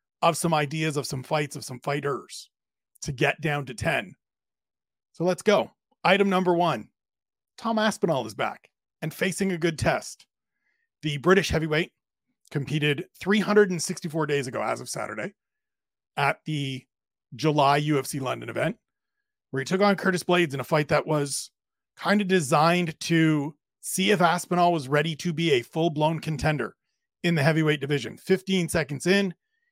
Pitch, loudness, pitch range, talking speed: 165 Hz, -25 LUFS, 145-190 Hz, 155 wpm